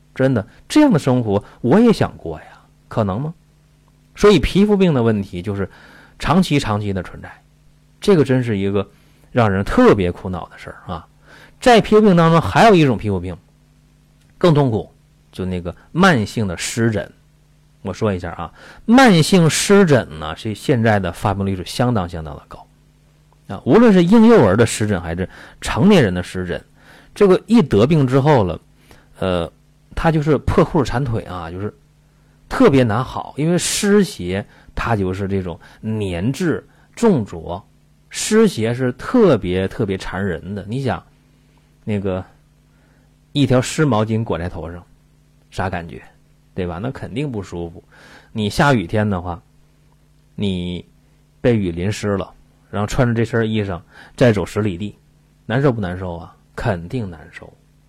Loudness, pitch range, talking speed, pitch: -17 LUFS, 95-150 Hz, 230 characters per minute, 120 Hz